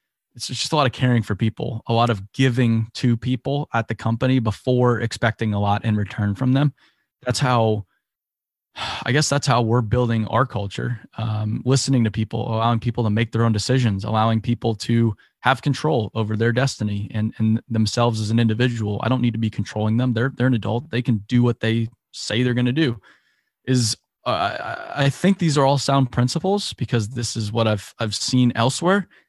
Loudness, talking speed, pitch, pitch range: -21 LUFS, 205 wpm, 120 Hz, 110-130 Hz